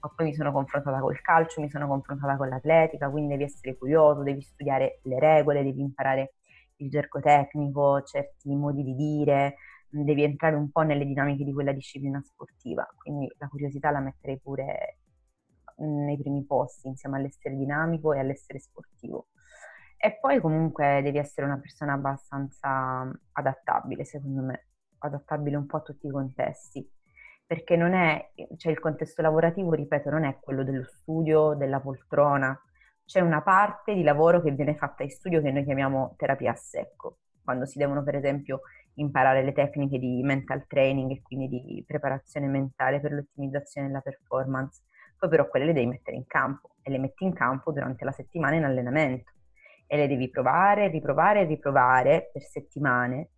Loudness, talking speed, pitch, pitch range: -27 LUFS, 165 wpm, 140 Hz, 135-150 Hz